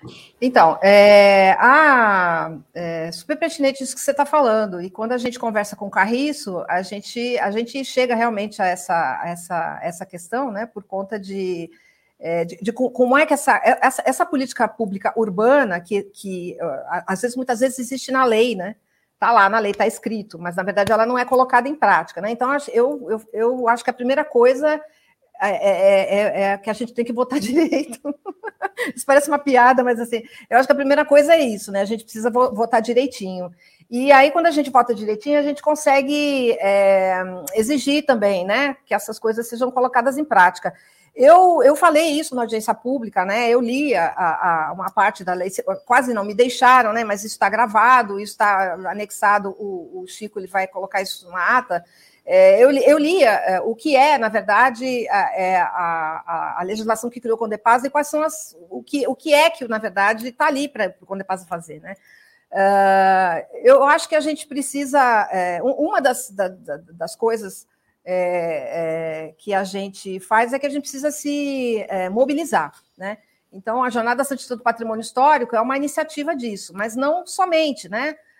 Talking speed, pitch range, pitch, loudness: 195 wpm, 195-275 Hz, 235 Hz, -18 LUFS